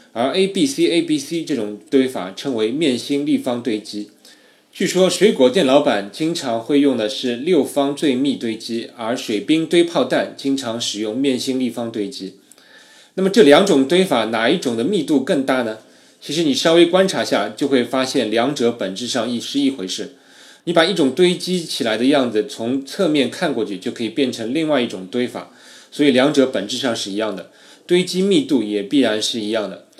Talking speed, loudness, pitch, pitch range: 285 characters per minute, -18 LUFS, 135 Hz, 115-170 Hz